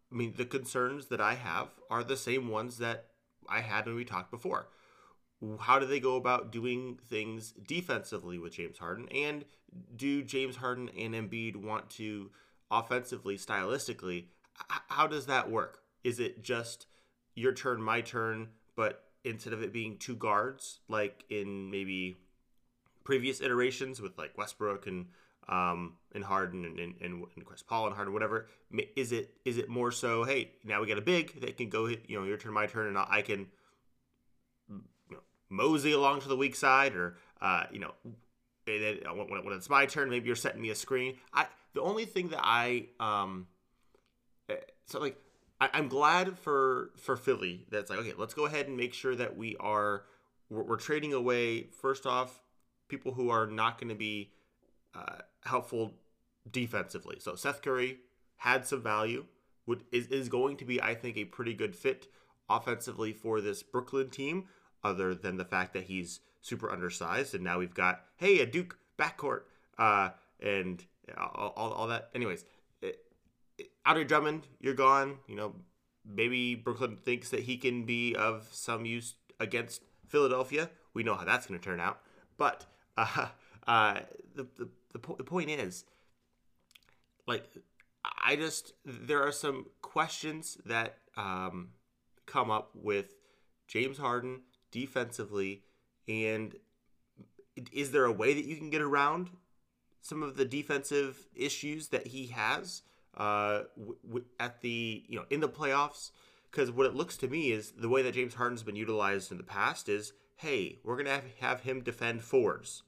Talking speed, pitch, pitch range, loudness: 170 wpm, 120 Hz, 105-135 Hz, -34 LUFS